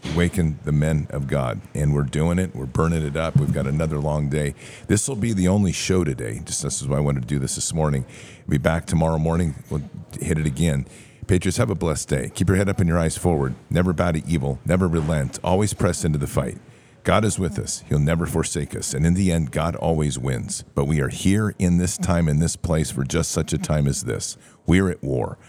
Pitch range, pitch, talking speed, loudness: 75-95 Hz, 80 Hz, 245 wpm, -22 LUFS